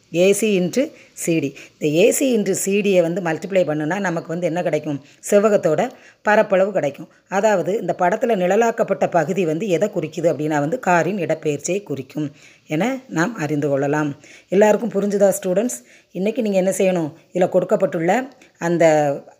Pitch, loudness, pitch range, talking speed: 180 Hz, -19 LUFS, 155-205 Hz, 135 wpm